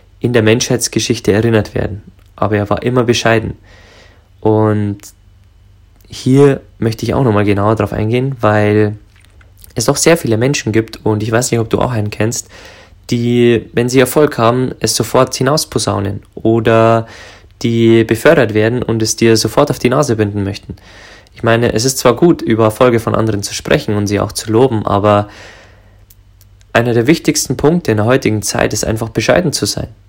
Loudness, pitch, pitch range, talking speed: -13 LUFS, 110 Hz, 100-120 Hz, 175 wpm